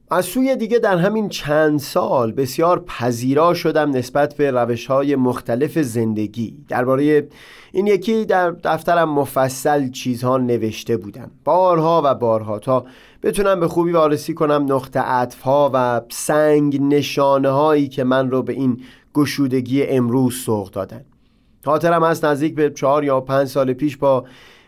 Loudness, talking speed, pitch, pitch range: -18 LUFS, 145 wpm, 140 Hz, 125-155 Hz